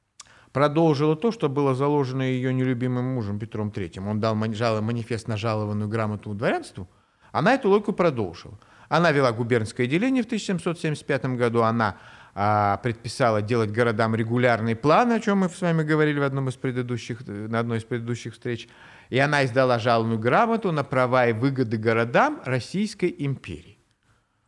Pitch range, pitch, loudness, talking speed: 115-145 Hz, 125 Hz, -24 LUFS, 150 wpm